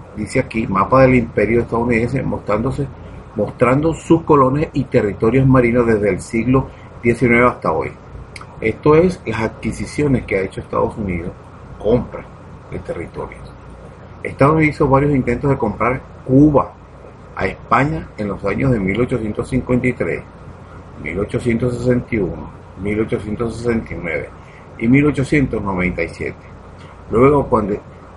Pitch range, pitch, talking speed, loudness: 105-130 Hz, 120 Hz, 110 wpm, -17 LUFS